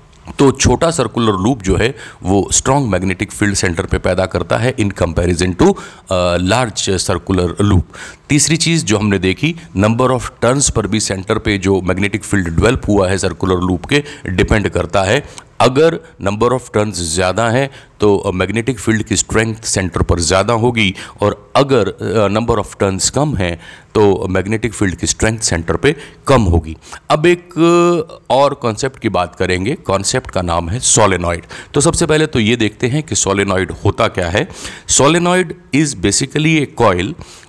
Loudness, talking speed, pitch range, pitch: -14 LUFS, 170 wpm, 95-130 Hz, 105 Hz